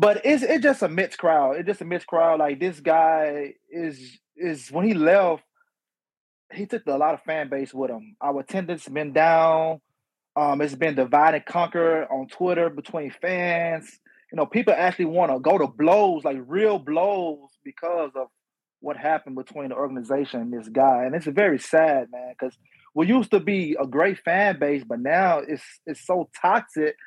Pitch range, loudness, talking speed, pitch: 145-180 Hz, -23 LUFS, 190 wpm, 160 Hz